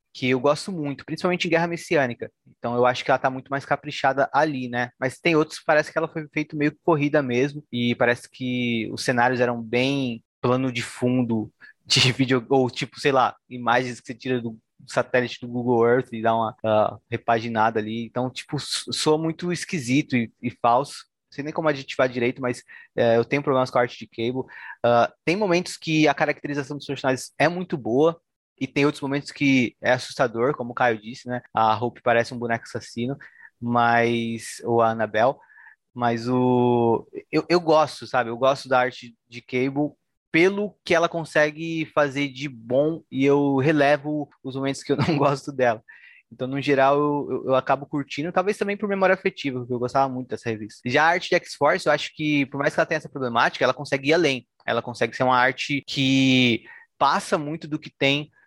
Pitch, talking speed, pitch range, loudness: 135 Hz, 200 wpm, 120-150 Hz, -23 LUFS